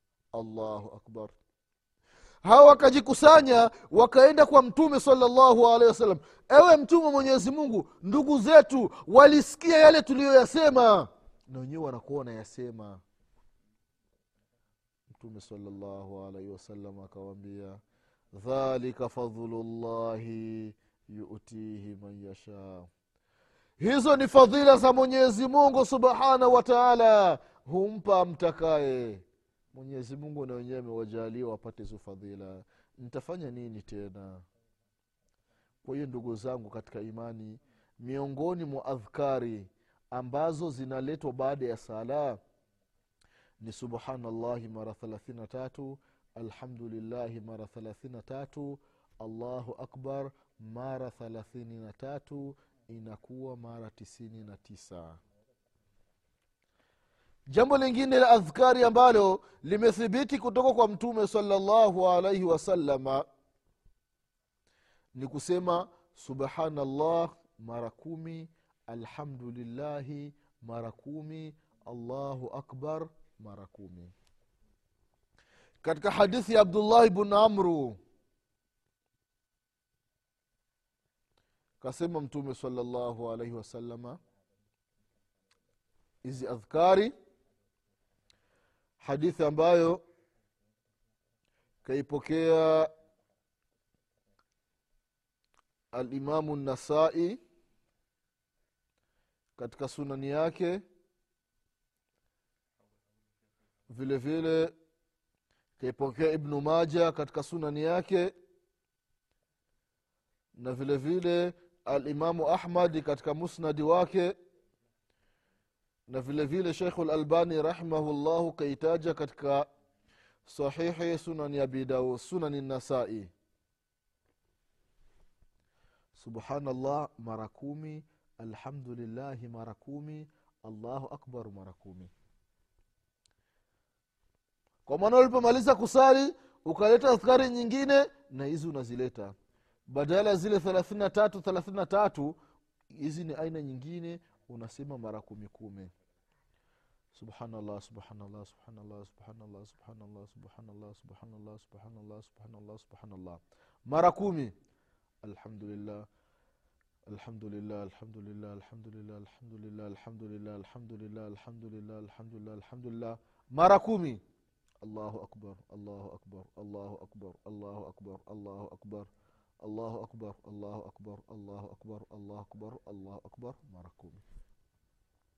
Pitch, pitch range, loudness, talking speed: 125 Hz, 105-165 Hz, -25 LUFS, 90 wpm